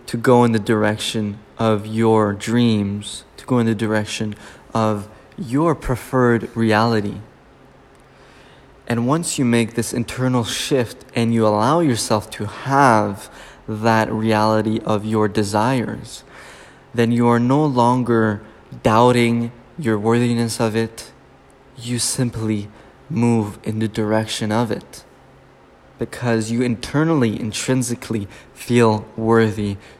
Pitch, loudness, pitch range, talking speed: 115 Hz, -19 LUFS, 110-120 Hz, 120 wpm